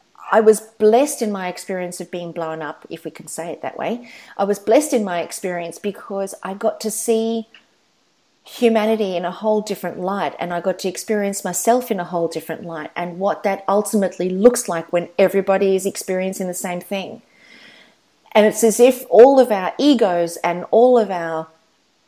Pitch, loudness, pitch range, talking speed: 195 Hz, -19 LUFS, 175-220 Hz, 190 wpm